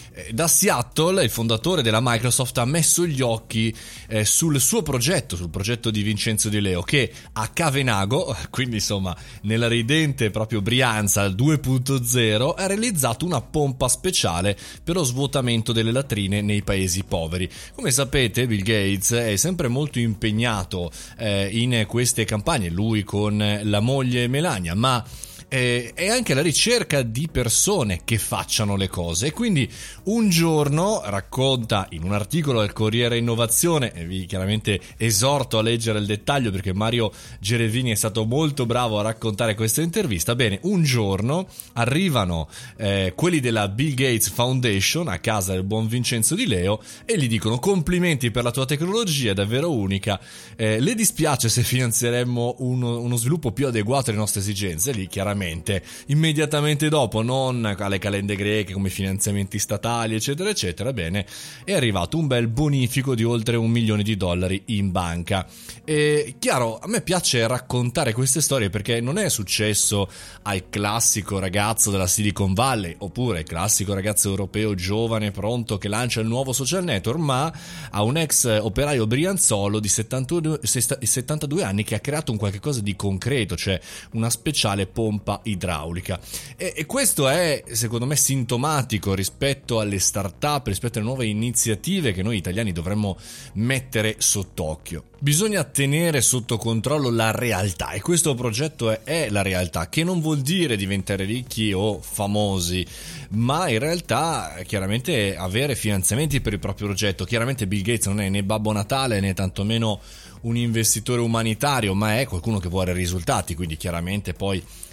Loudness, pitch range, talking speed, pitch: -22 LUFS, 100-135 Hz, 150 wpm, 115 Hz